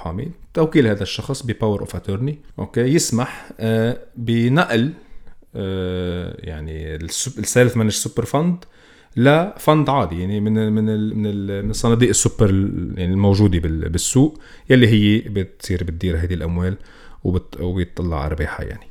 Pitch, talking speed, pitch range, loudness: 105 Hz, 115 wpm, 90-125 Hz, -19 LUFS